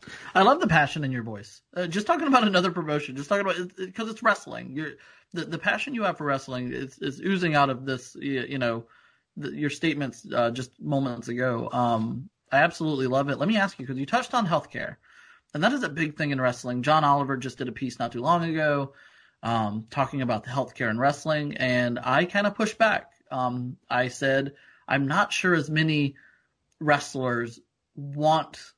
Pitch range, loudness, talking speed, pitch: 125-165 Hz, -26 LUFS, 210 wpm, 140 Hz